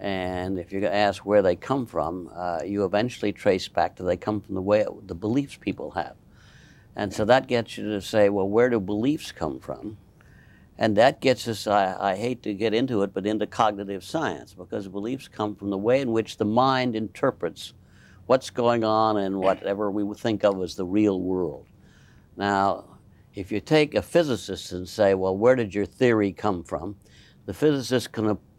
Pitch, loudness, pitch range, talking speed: 105 Hz, -25 LUFS, 100-115 Hz, 190 wpm